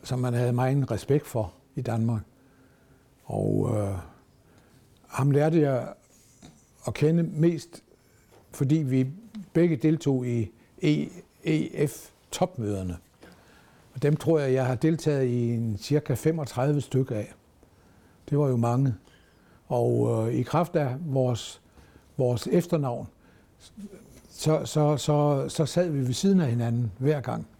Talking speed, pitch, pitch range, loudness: 125 wpm, 130 Hz, 115-150 Hz, -26 LUFS